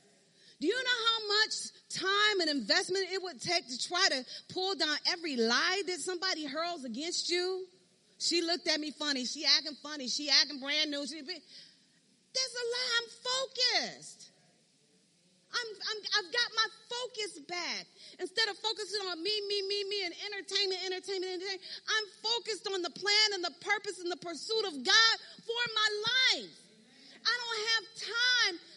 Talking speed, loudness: 165 wpm, -31 LUFS